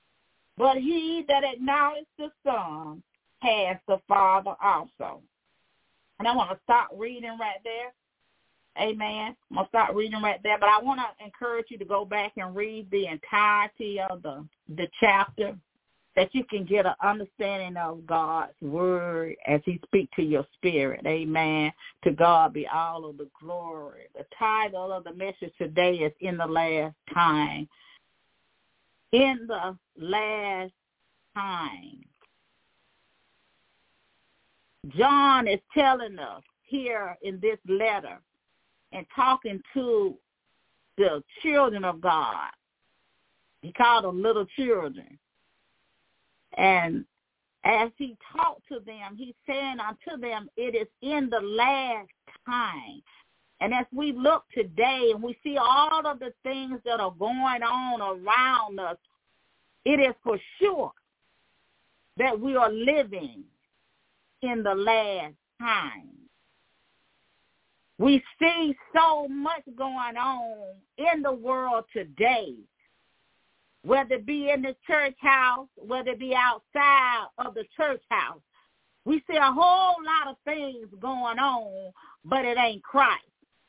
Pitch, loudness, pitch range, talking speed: 230 Hz, -26 LUFS, 195-270 Hz, 135 wpm